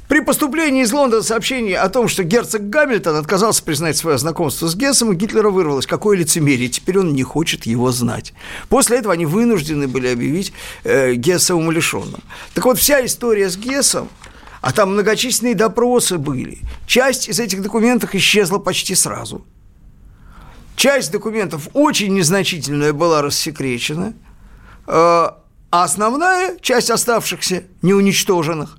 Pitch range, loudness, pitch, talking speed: 165-235 Hz, -16 LUFS, 195 Hz, 130 wpm